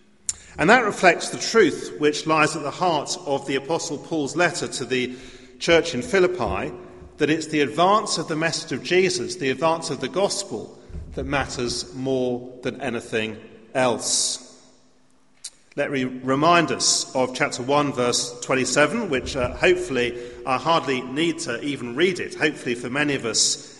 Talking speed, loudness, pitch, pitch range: 160 wpm, -22 LUFS, 140 Hz, 125-165 Hz